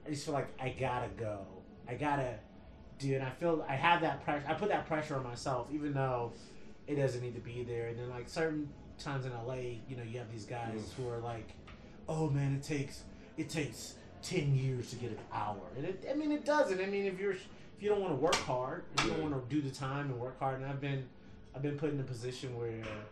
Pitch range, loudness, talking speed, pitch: 120-150 Hz, -37 LUFS, 255 wpm, 130 Hz